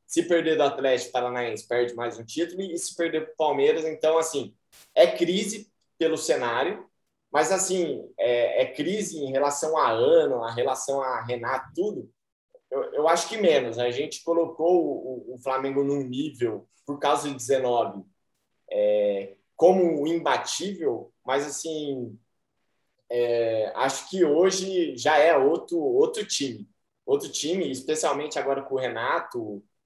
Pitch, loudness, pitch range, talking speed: 155 Hz, -25 LUFS, 130-190 Hz, 150 wpm